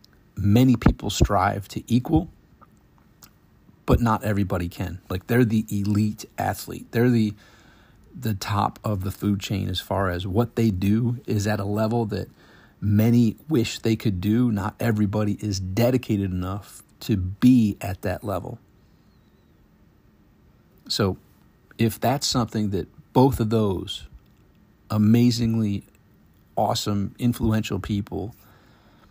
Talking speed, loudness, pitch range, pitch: 125 wpm, -23 LUFS, 100-115 Hz, 105 Hz